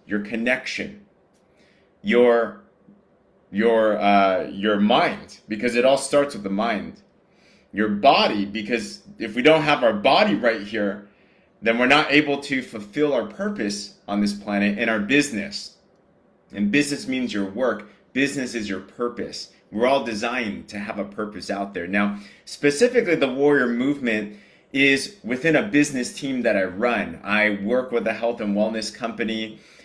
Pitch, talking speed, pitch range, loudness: 110 Hz, 155 wpm, 105-135 Hz, -22 LUFS